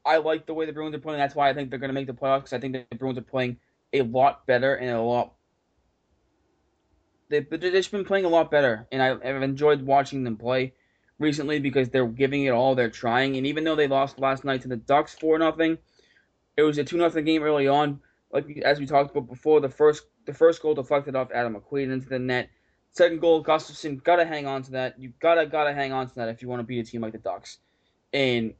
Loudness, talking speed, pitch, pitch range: -25 LUFS, 250 wpm, 140 Hz, 130-150 Hz